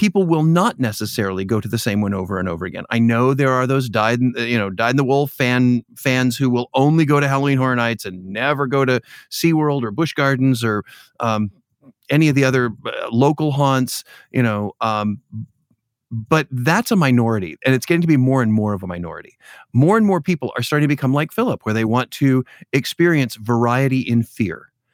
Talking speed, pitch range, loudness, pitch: 205 wpm, 115-140 Hz, -18 LUFS, 125 Hz